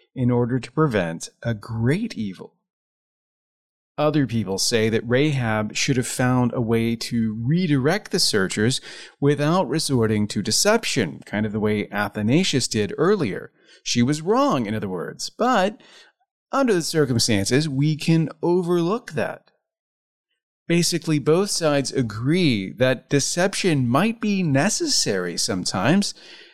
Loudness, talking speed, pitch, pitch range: -21 LUFS, 125 wpm, 140 Hz, 115-175 Hz